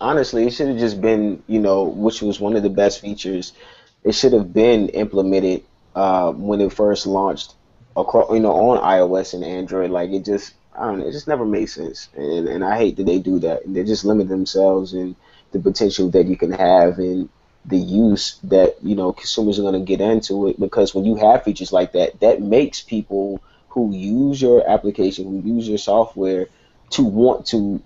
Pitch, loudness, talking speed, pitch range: 100 Hz, -18 LUFS, 210 wpm, 95-110 Hz